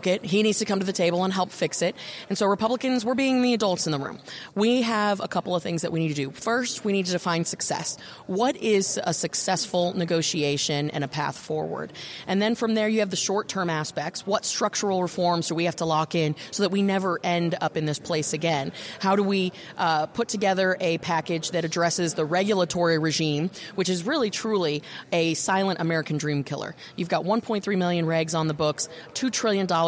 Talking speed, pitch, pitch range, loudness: 220 wpm, 180 Hz, 165-200 Hz, -25 LUFS